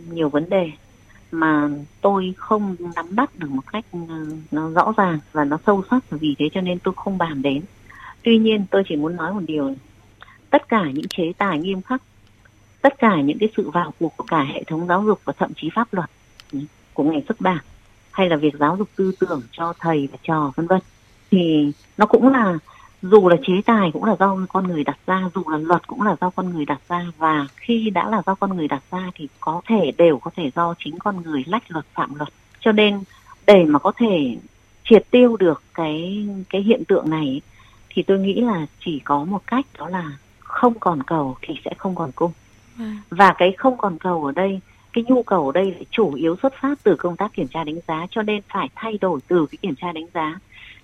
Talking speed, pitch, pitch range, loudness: 225 wpm, 175 Hz, 150-205 Hz, -20 LUFS